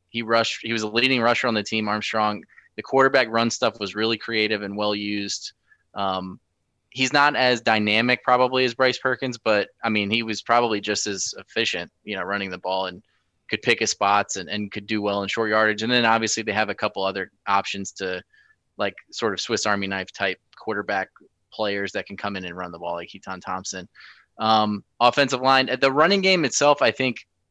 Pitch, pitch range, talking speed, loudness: 110 Hz, 100-120 Hz, 210 wpm, -22 LUFS